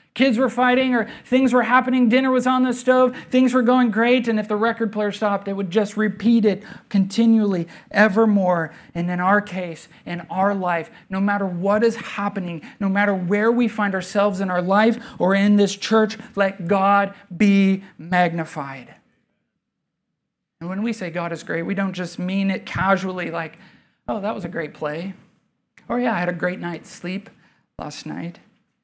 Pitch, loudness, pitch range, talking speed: 200 Hz, -20 LUFS, 185-225 Hz, 185 wpm